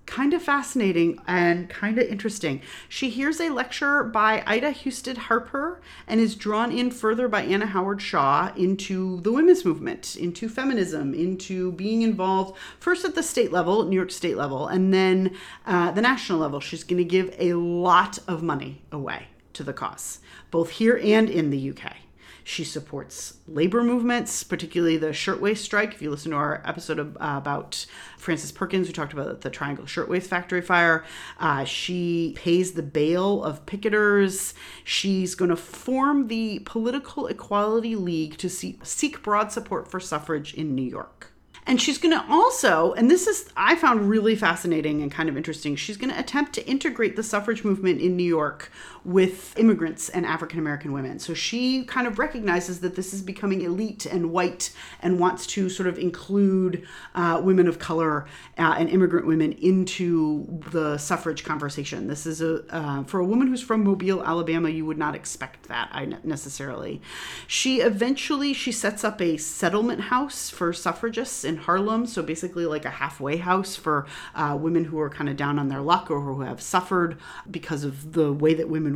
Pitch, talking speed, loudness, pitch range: 180 Hz, 175 wpm, -24 LUFS, 160-220 Hz